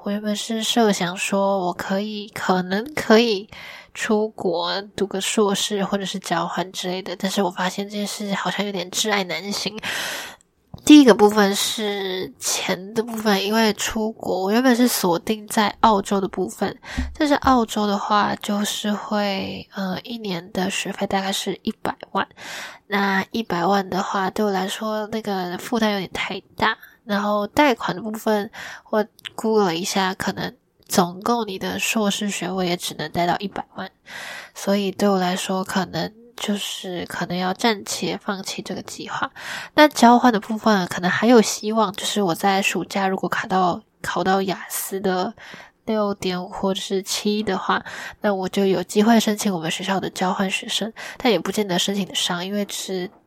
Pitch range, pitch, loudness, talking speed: 185-215 Hz, 200 Hz, -21 LUFS, 255 characters per minute